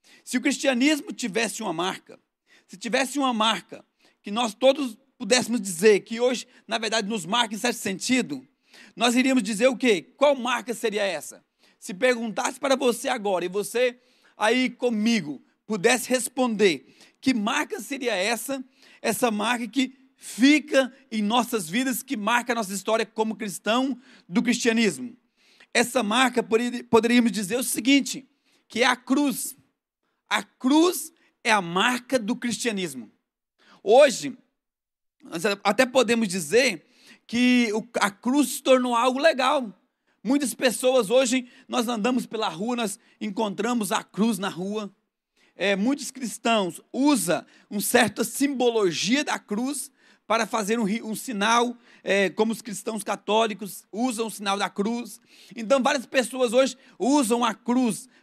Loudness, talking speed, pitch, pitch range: -24 LUFS, 140 wpm, 240 Hz, 220-260 Hz